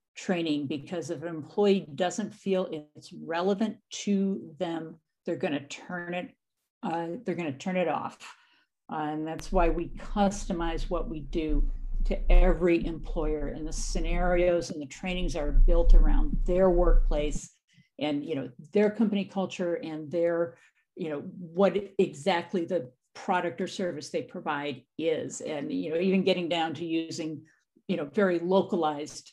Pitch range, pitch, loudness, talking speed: 160-190 Hz, 170 Hz, -30 LUFS, 160 wpm